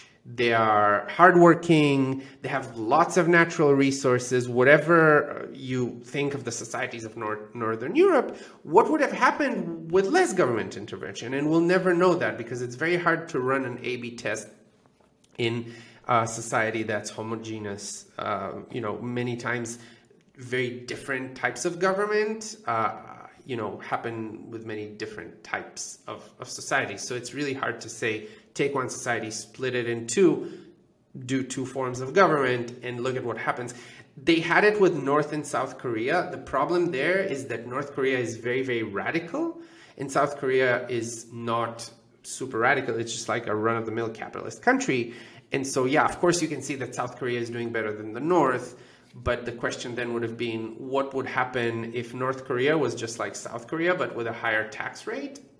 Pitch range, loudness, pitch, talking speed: 115-150 Hz, -26 LUFS, 125 Hz, 180 wpm